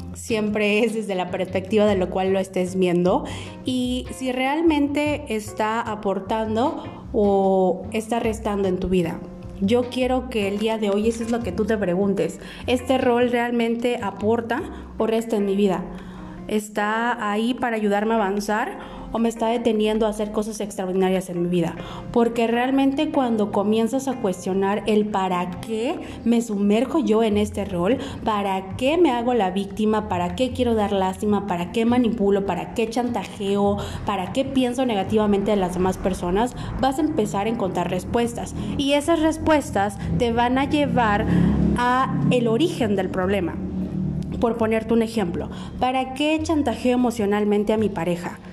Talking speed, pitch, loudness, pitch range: 160 wpm, 215 Hz, -22 LUFS, 195-240 Hz